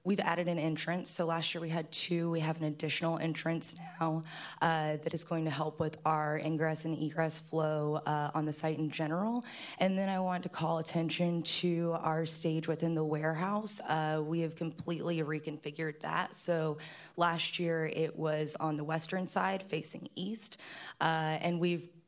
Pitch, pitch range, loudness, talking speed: 160 Hz, 155-170 Hz, -34 LUFS, 180 wpm